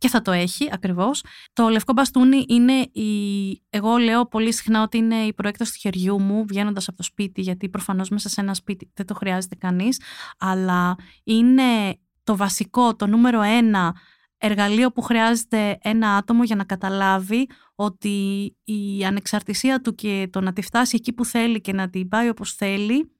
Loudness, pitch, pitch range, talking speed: -21 LUFS, 210 Hz, 195-230 Hz, 175 wpm